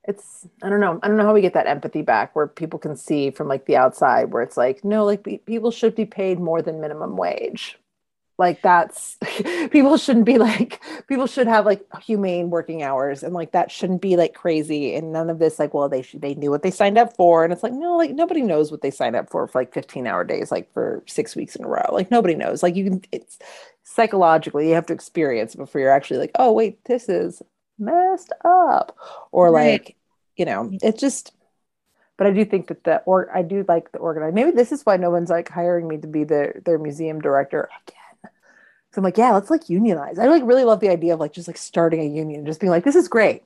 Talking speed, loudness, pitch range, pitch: 245 wpm, -20 LUFS, 160-220 Hz, 180 Hz